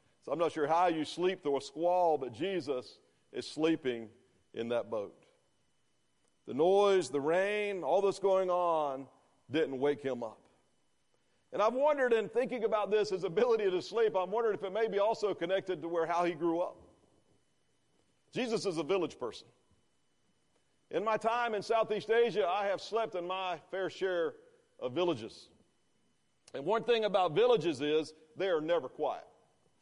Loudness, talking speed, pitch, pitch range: -33 LUFS, 165 wpm, 190 Hz, 160-225 Hz